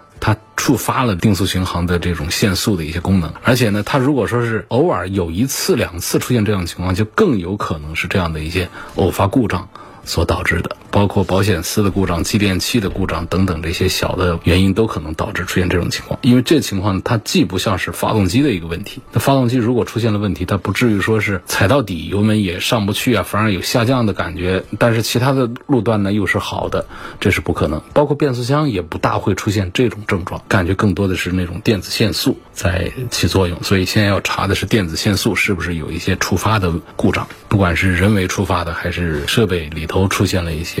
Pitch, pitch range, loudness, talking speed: 100 Hz, 90-110 Hz, -17 LUFS, 345 characters per minute